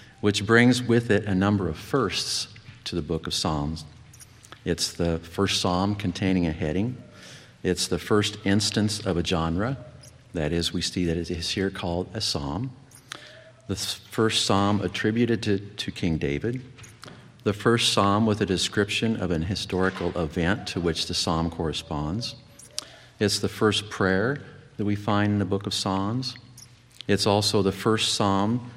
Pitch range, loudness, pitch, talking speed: 90-115 Hz, -25 LUFS, 100 Hz, 165 wpm